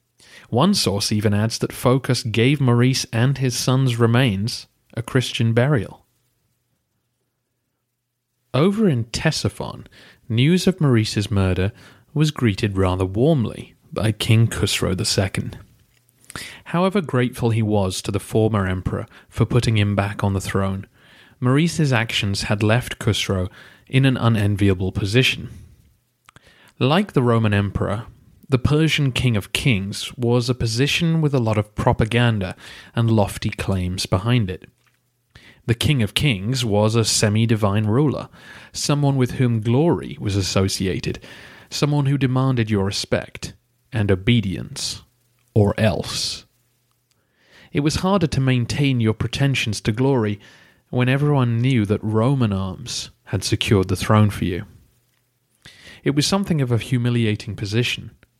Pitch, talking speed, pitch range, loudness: 115 Hz, 130 wpm, 105-130 Hz, -20 LUFS